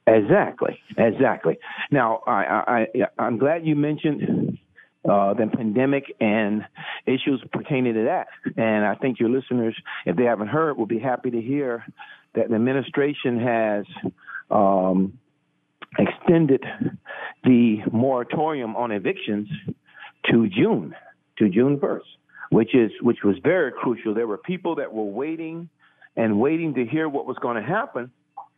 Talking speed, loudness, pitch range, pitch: 145 wpm, -22 LUFS, 110-145 Hz, 125 Hz